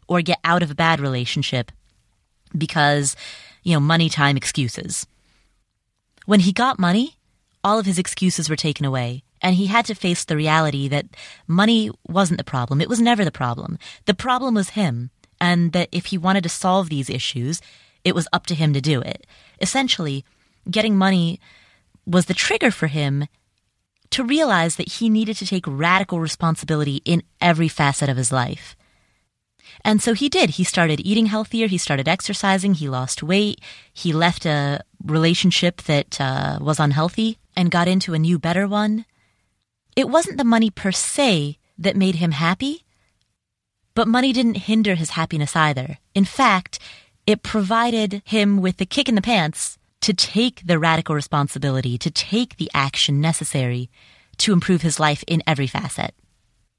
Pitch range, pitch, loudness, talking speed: 145-200 Hz, 170 Hz, -20 LUFS, 170 wpm